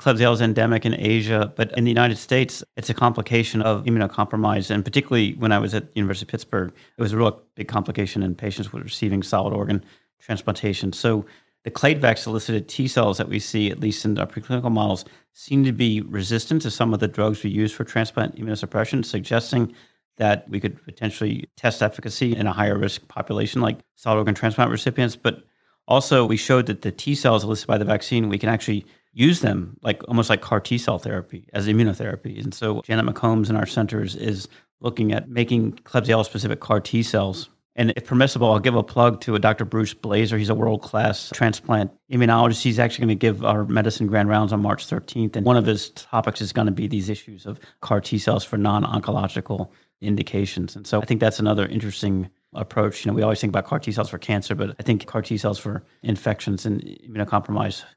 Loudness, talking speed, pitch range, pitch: -22 LUFS, 210 wpm, 105-115 Hz, 110 Hz